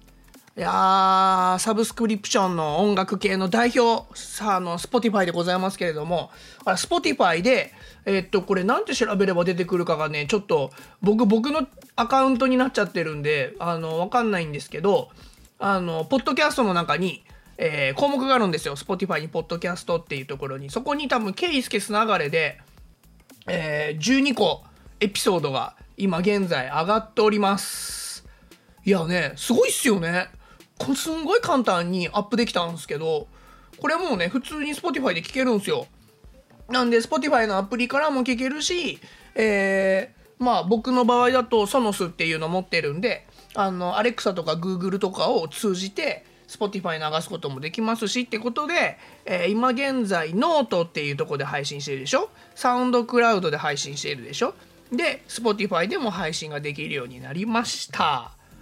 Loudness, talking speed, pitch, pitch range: -23 LUFS, 395 characters per minute, 205 Hz, 175-250 Hz